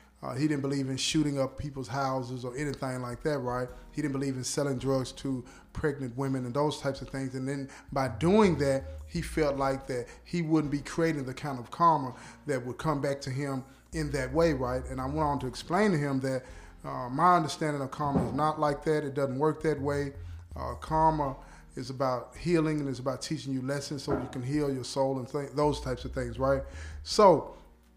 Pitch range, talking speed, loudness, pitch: 130-150 Hz, 220 wpm, -30 LUFS, 135 Hz